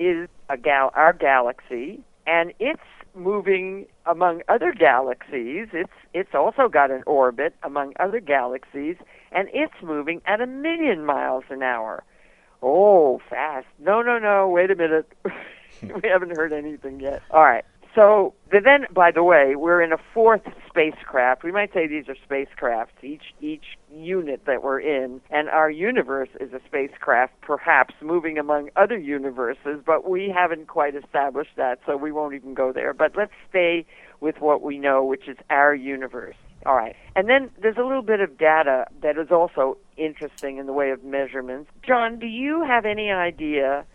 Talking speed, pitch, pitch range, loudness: 170 wpm, 155 Hz, 140-195 Hz, -21 LUFS